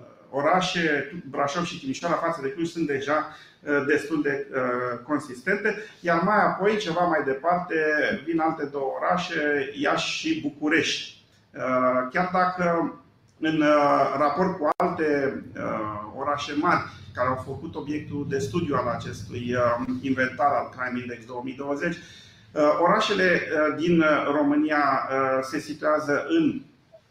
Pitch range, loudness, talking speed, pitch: 130-170 Hz, -25 LUFS, 115 wpm, 150 Hz